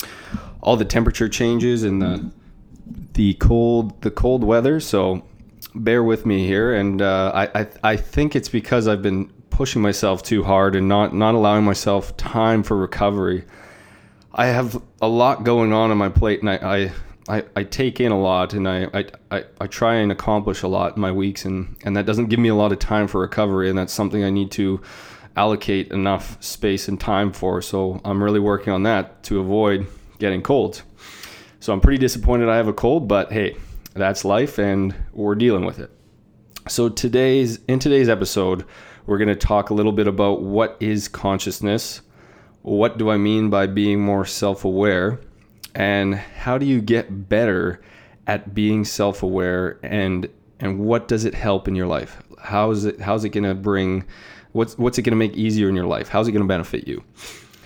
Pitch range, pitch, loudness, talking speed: 95-110 Hz, 105 Hz, -20 LUFS, 190 wpm